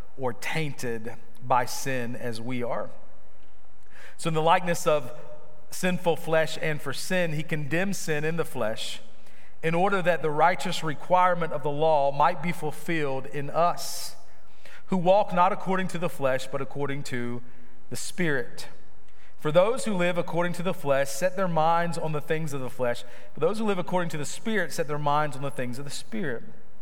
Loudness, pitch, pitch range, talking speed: -27 LUFS, 155 Hz, 135-175 Hz, 185 wpm